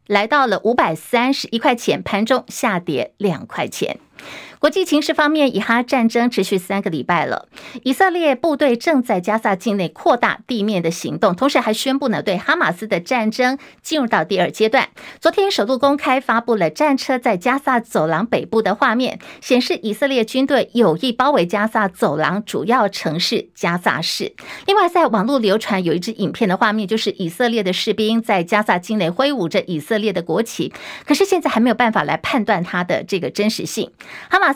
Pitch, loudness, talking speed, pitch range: 225 Hz, -18 LUFS, 300 characters per minute, 200-270 Hz